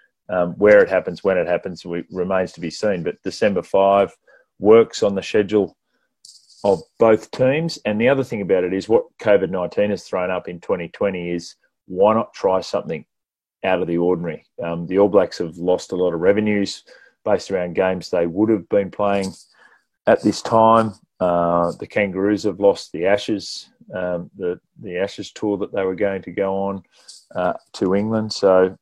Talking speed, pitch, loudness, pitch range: 185 wpm, 95 Hz, -20 LUFS, 90-105 Hz